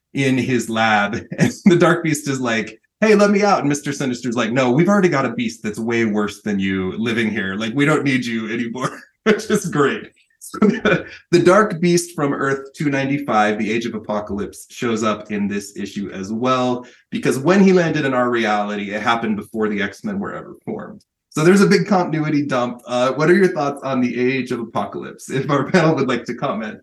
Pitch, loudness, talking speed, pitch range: 130 Hz, -18 LUFS, 215 wpm, 110-160 Hz